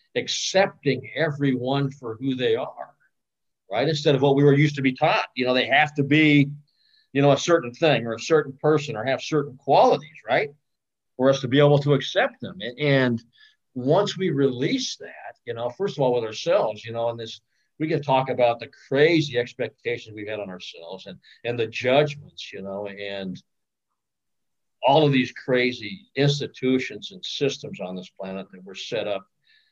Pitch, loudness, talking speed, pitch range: 135 Hz, -23 LUFS, 185 wpm, 120-150 Hz